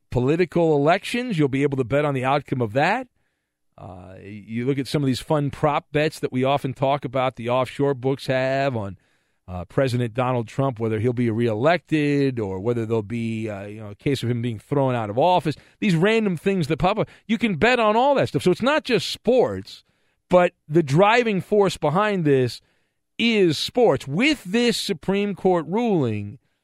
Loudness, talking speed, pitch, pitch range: -22 LUFS, 195 wpm, 140 Hz, 120-180 Hz